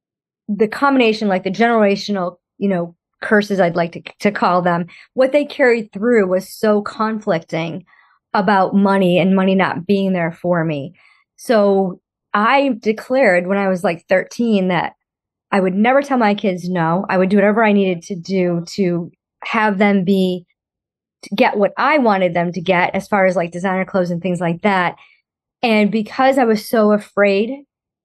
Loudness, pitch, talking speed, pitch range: -16 LUFS, 195 Hz, 175 wpm, 180-220 Hz